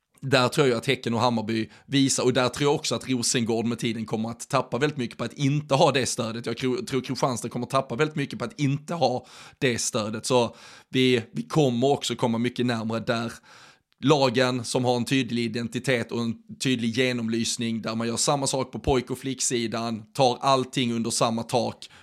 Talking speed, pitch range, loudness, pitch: 205 wpm, 115-135 Hz, -25 LUFS, 125 Hz